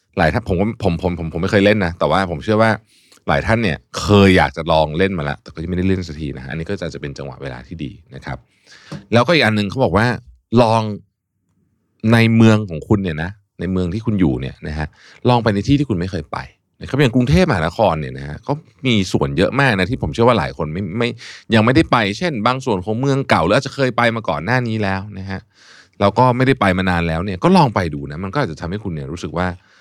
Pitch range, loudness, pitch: 90-115 Hz, -17 LUFS, 100 Hz